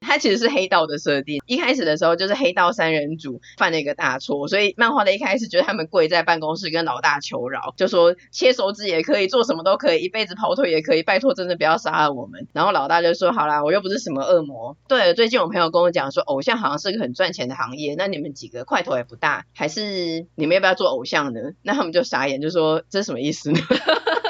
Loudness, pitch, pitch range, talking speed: -20 LUFS, 170 Hz, 155-215 Hz, 385 characters per minute